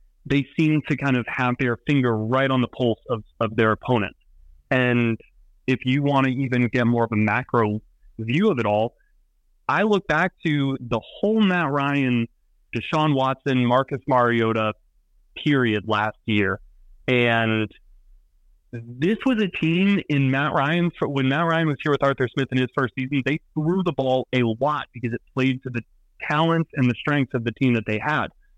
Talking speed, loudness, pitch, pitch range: 185 wpm, -22 LUFS, 130 Hz, 115-145 Hz